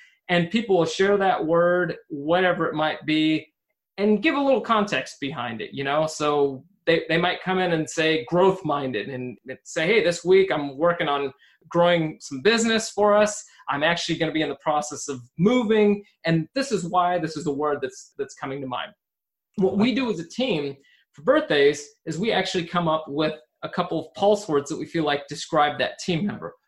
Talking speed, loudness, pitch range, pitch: 200 wpm, -23 LUFS, 150-200 Hz, 165 Hz